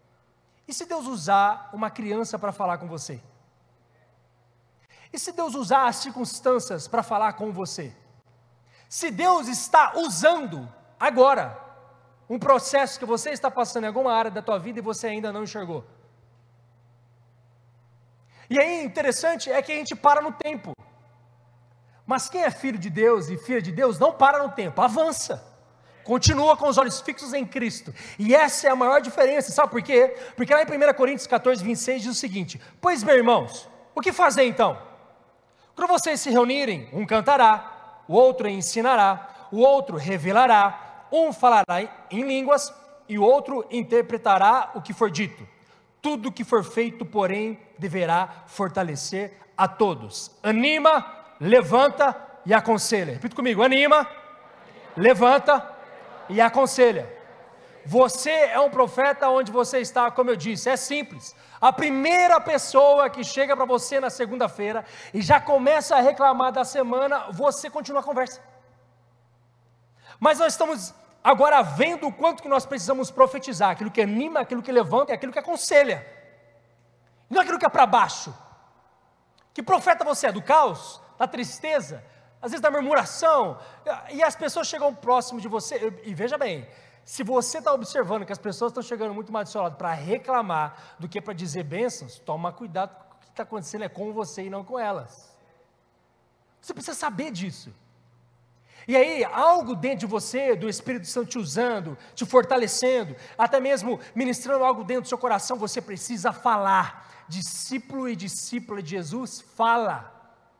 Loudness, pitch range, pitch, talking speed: -22 LUFS, 195-275 Hz, 240 Hz, 160 wpm